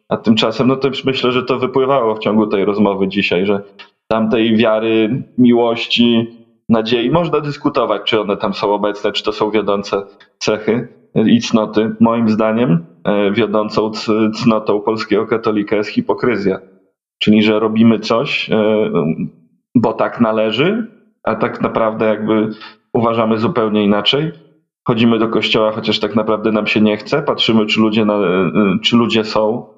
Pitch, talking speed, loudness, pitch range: 110 Hz, 145 wpm, -15 LUFS, 105-120 Hz